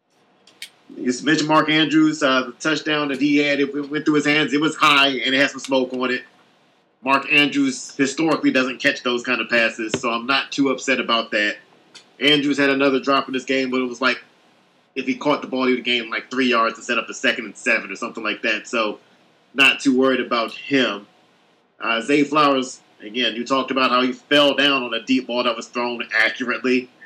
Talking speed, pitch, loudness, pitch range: 220 wpm, 130 Hz, -19 LUFS, 125-145 Hz